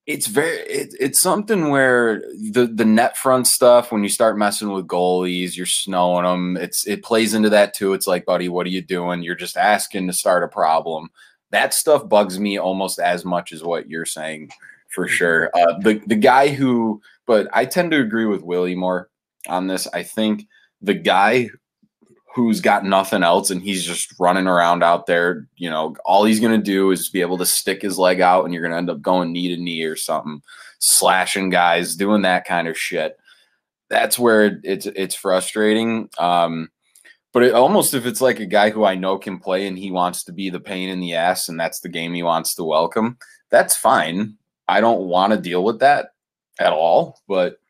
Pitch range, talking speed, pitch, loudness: 90-110 Hz, 205 wpm, 95 Hz, -18 LUFS